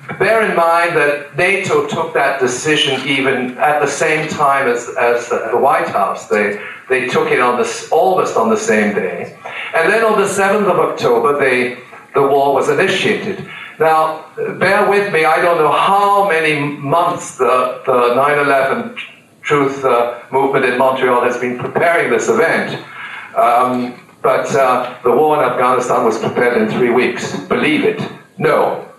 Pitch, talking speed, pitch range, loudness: 145 Hz, 165 wpm, 130-175 Hz, -14 LUFS